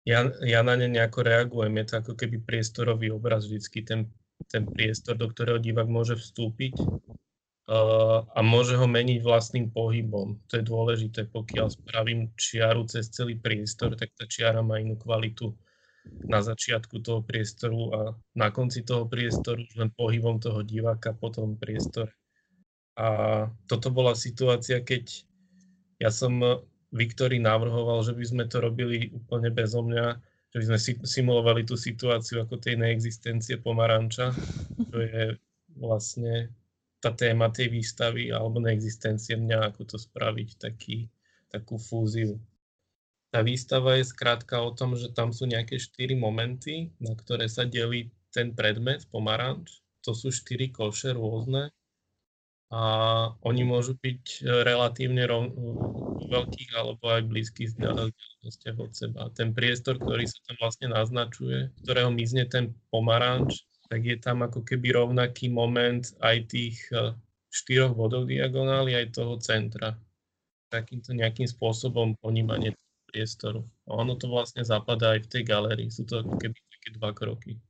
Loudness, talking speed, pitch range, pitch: -28 LUFS, 145 wpm, 110-120 Hz, 115 Hz